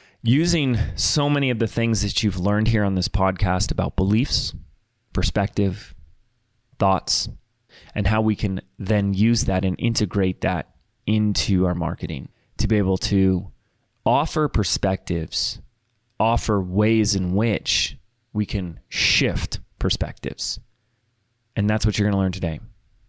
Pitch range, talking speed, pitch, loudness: 95-115 Hz, 135 wpm, 105 Hz, -22 LUFS